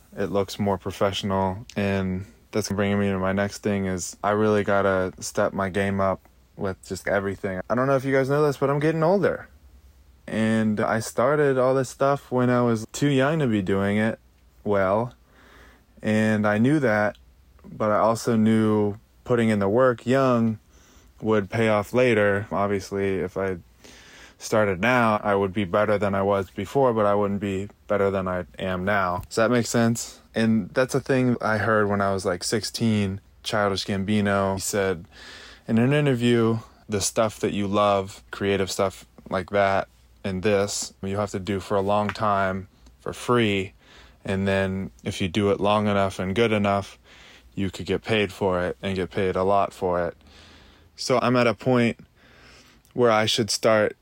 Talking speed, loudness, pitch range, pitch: 185 wpm, -23 LUFS, 95-110 Hz, 100 Hz